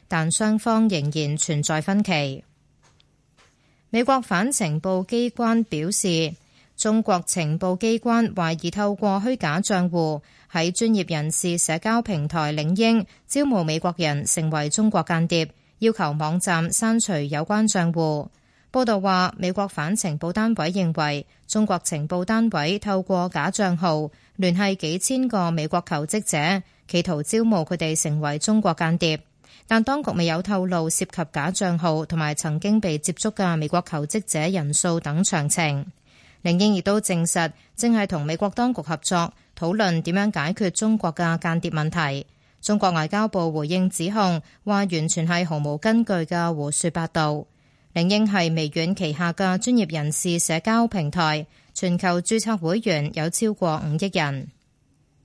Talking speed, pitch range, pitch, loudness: 235 characters per minute, 155-205 Hz, 175 Hz, -23 LUFS